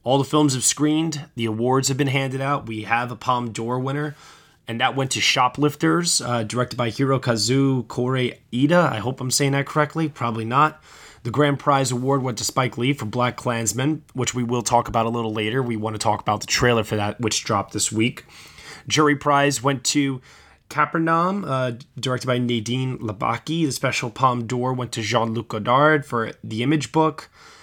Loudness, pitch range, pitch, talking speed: -21 LUFS, 115-145 Hz, 125 Hz, 195 wpm